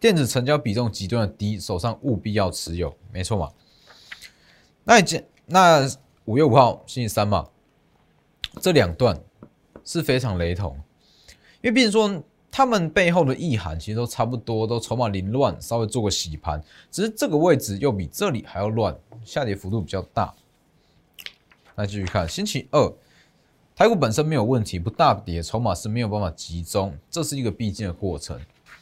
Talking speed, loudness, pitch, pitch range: 260 characters per minute, -22 LUFS, 110 Hz, 95-135 Hz